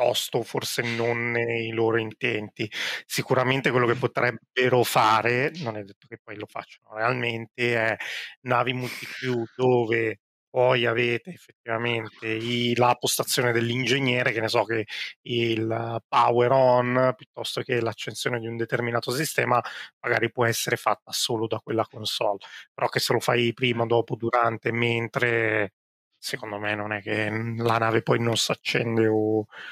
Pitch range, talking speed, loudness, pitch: 115-125 Hz, 145 wpm, -25 LUFS, 115 Hz